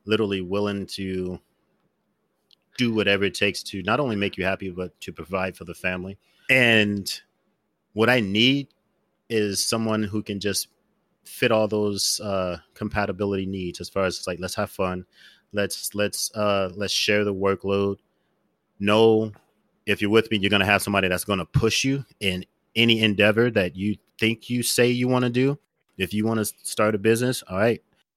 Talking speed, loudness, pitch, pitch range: 175 wpm, -23 LUFS, 105 Hz, 95-110 Hz